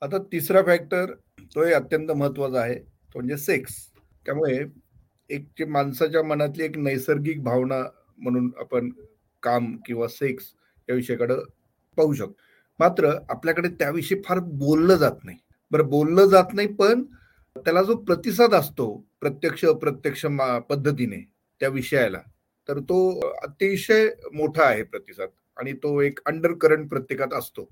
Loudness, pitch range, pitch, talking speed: -23 LUFS, 130-180 Hz, 150 Hz, 130 wpm